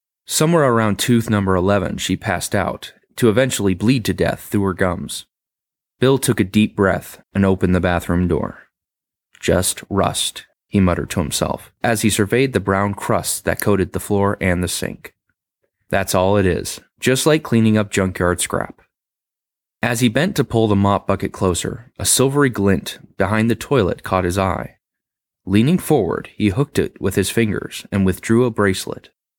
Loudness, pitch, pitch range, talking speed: -18 LUFS, 100 Hz, 95-115 Hz, 175 wpm